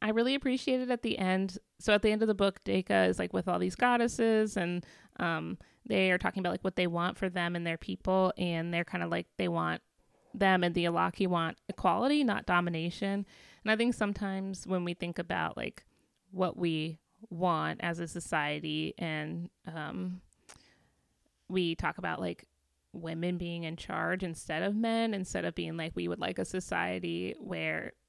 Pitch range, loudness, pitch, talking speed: 165-200 Hz, -32 LUFS, 180 Hz, 190 wpm